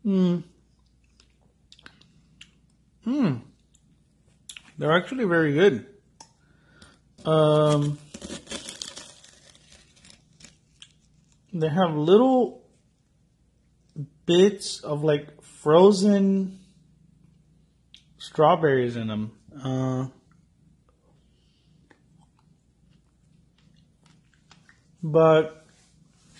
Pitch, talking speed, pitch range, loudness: 160 Hz, 45 wpm, 150-185 Hz, -23 LUFS